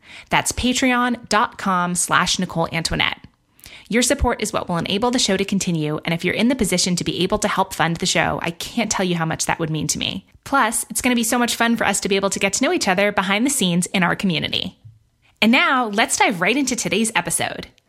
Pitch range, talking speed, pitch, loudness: 170-235 Hz, 245 wpm, 195 Hz, -19 LUFS